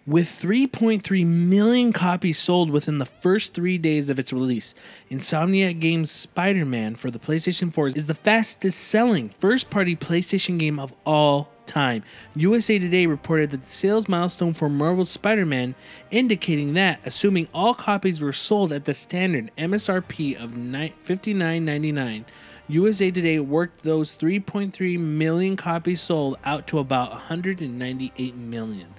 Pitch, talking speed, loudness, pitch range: 165 Hz, 135 wpm, -23 LUFS, 145-190 Hz